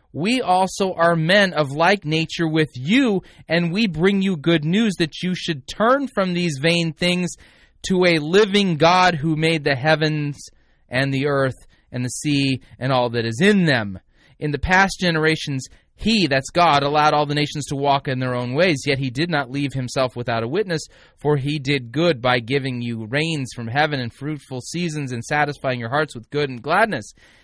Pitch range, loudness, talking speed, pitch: 135-175 Hz, -20 LUFS, 195 wpm, 150 Hz